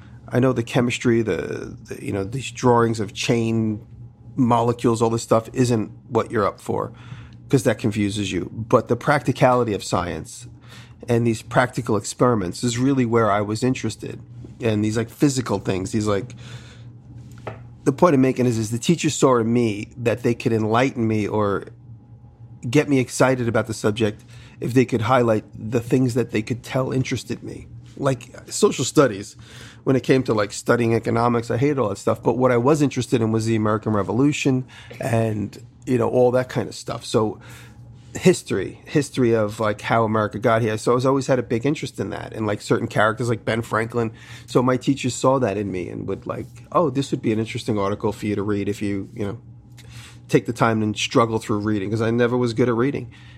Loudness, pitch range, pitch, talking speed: -21 LUFS, 110-125 Hz, 120 Hz, 200 wpm